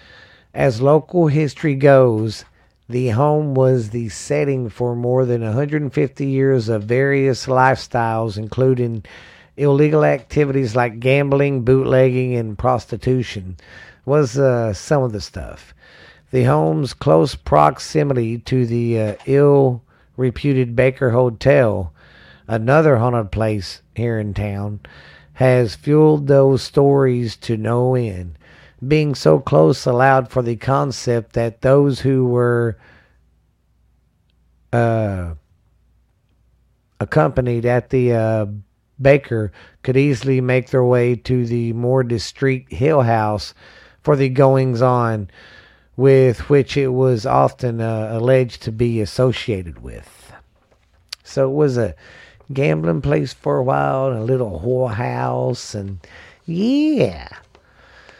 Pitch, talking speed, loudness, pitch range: 125 Hz, 120 wpm, -17 LUFS, 110-135 Hz